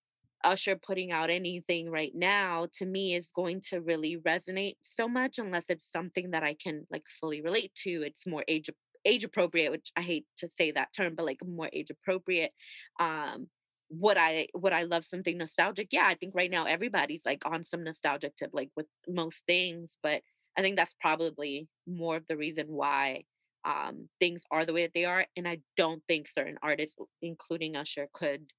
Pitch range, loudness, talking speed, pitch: 160-180 Hz, -32 LUFS, 195 wpm, 170 Hz